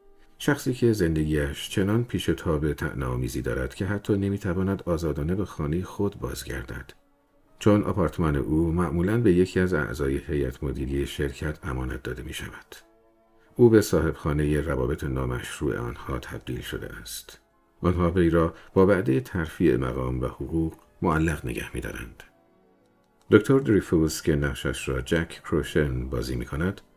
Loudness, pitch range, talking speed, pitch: -26 LUFS, 65-95 Hz, 140 wpm, 80 Hz